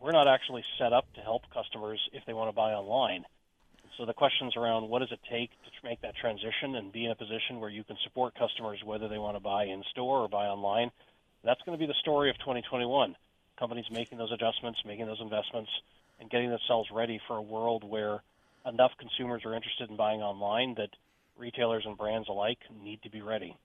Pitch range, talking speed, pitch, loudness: 105-120 Hz, 215 wpm, 115 Hz, -33 LUFS